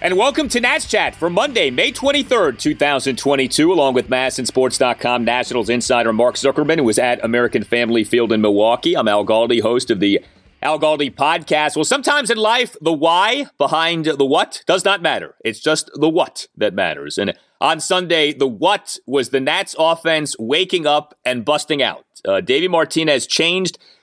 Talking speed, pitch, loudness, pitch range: 175 wpm, 150 Hz, -16 LUFS, 125-165 Hz